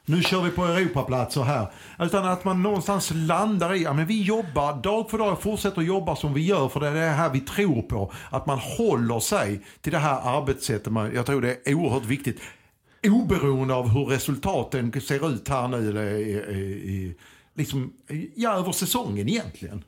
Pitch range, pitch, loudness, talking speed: 125-180 Hz, 145 Hz, -25 LUFS, 190 wpm